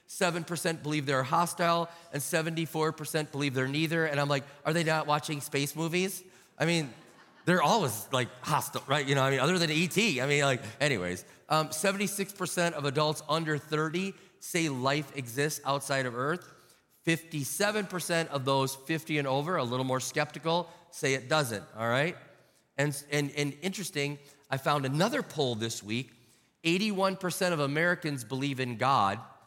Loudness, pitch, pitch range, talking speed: -30 LUFS, 150 Hz, 135-170 Hz, 160 wpm